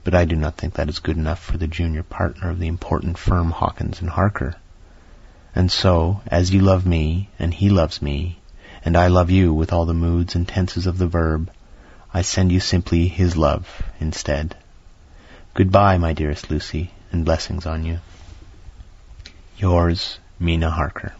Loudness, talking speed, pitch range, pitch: -20 LUFS, 175 wpm, 80-90 Hz, 85 Hz